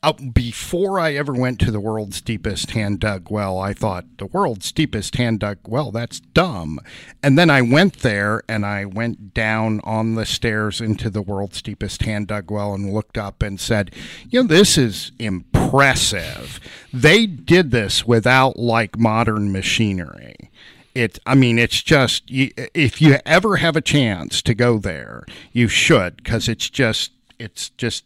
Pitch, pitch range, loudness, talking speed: 115 Hz, 105-130 Hz, -18 LUFS, 170 wpm